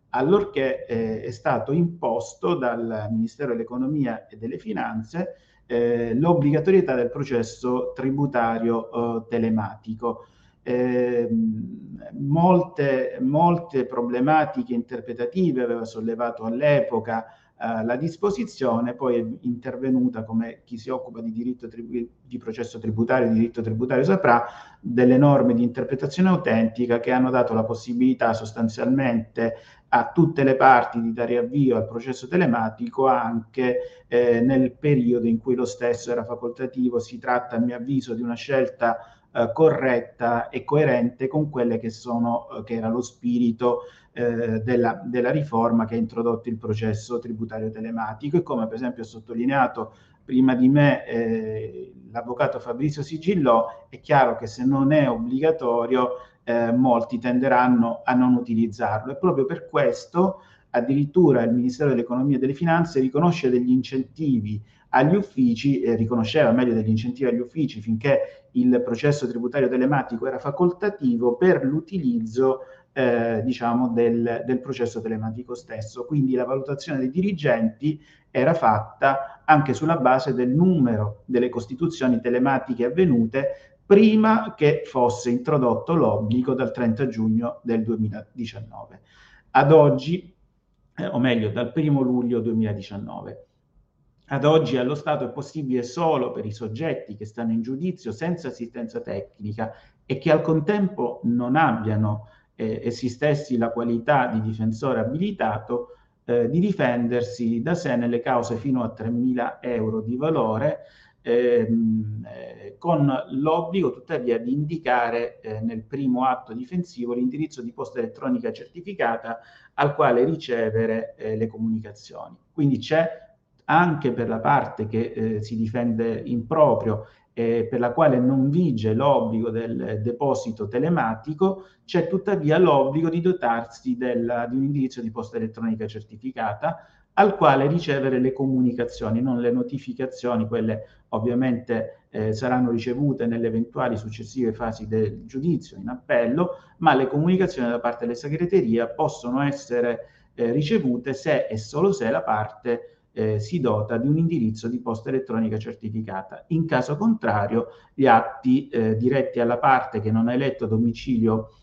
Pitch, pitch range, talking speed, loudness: 120 Hz, 115-140 Hz, 140 wpm, -23 LUFS